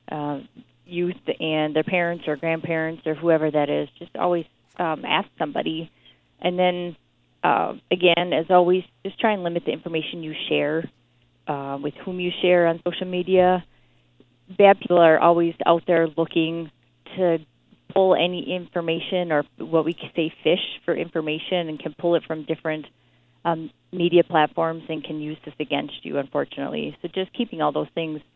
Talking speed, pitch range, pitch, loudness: 165 wpm, 150-175 Hz, 165 Hz, -23 LUFS